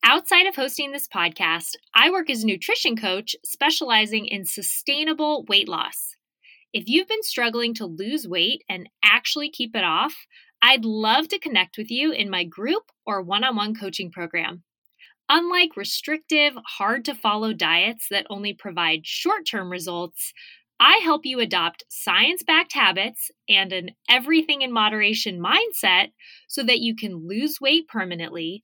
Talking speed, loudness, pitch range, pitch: 155 wpm, -21 LUFS, 195-305 Hz, 230 Hz